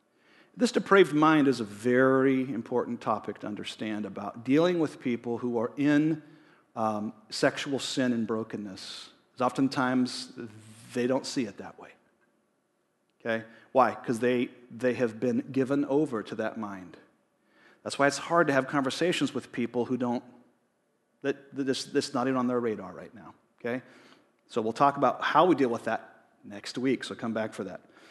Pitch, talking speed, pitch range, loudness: 125 Hz, 170 wpm, 115-140 Hz, -28 LUFS